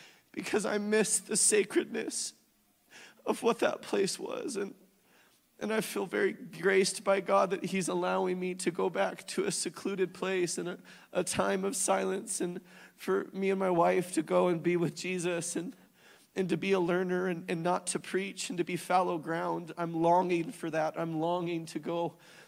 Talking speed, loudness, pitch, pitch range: 185 wpm, -31 LUFS, 180 Hz, 175-195 Hz